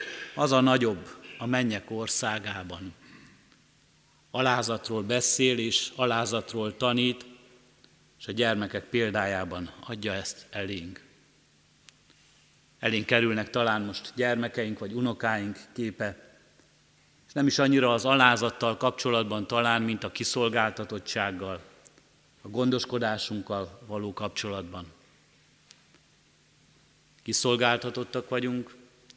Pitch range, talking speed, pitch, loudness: 105-125 Hz, 90 wpm, 115 Hz, -27 LUFS